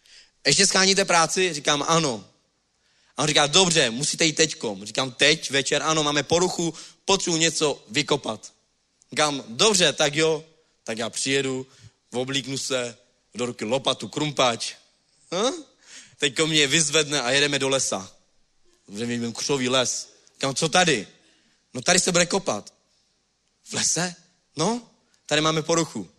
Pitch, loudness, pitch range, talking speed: 150 Hz, -22 LUFS, 135-170 Hz, 140 wpm